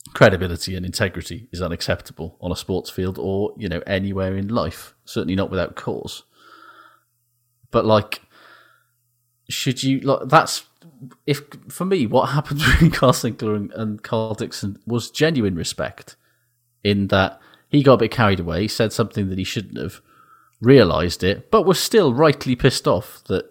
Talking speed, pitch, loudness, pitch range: 165 wpm, 115 Hz, -20 LUFS, 95-130 Hz